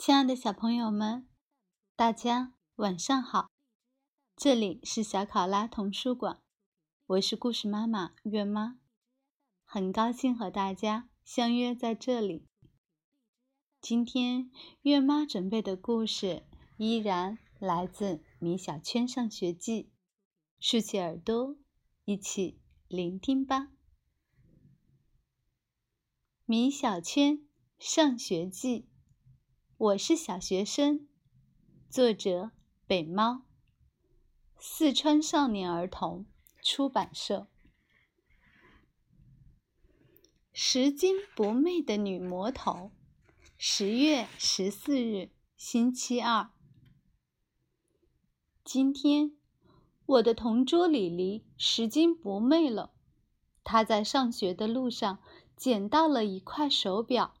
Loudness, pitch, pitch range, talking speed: -30 LUFS, 230 Hz, 195-265 Hz, 140 characters per minute